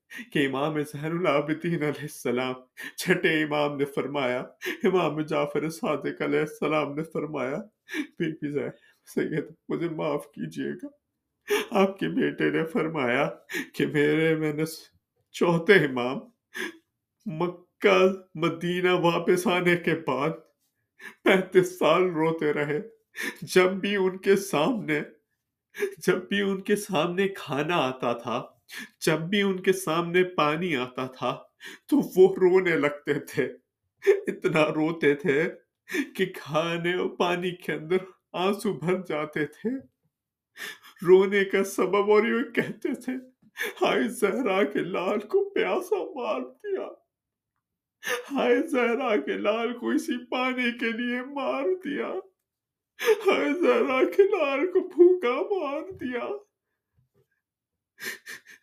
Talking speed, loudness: 120 wpm, -26 LUFS